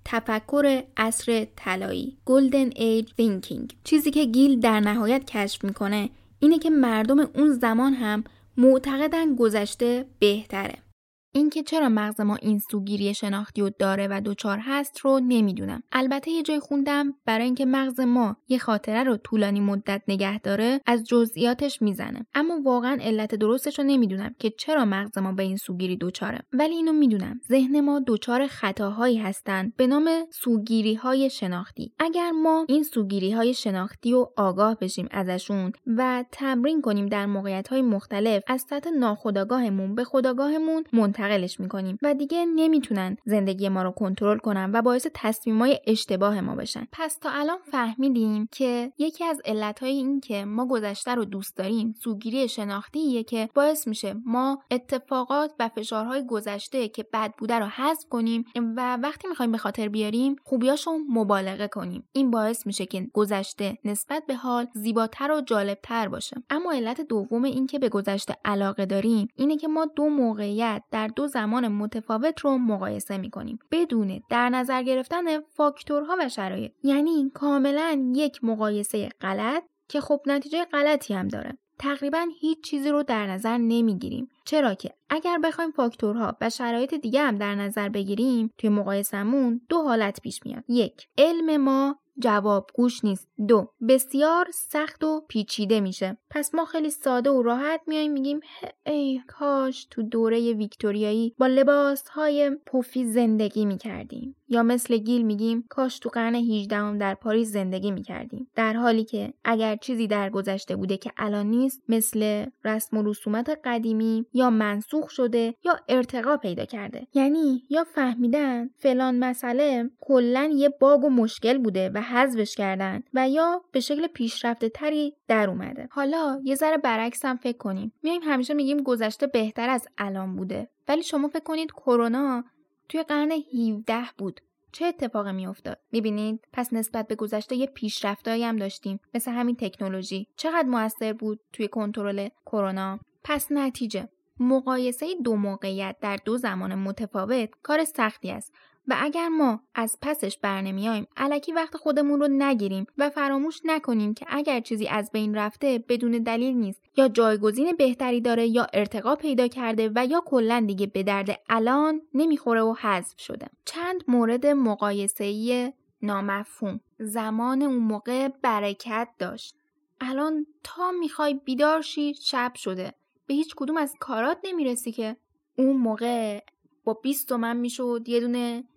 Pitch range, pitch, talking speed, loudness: 215-280 Hz, 240 Hz, 150 wpm, -25 LUFS